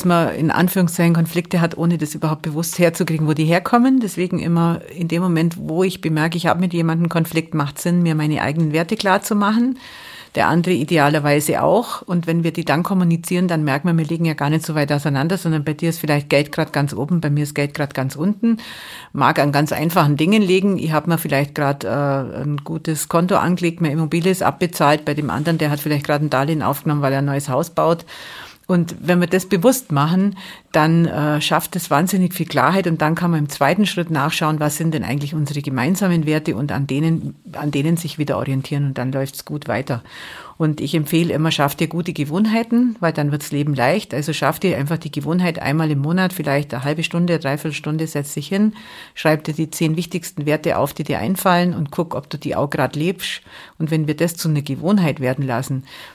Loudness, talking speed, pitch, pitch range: -19 LUFS, 220 wpm, 160 Hz, 145-175 Hz